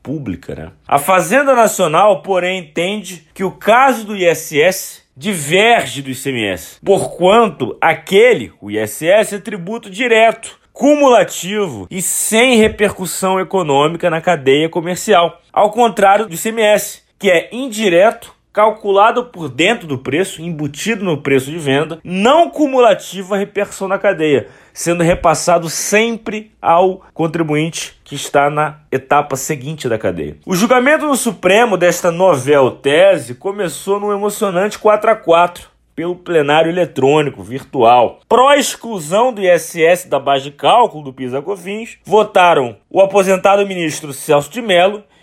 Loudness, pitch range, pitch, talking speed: -13 LUFS, 160-215 Hz, 185 Hz, 130 wpm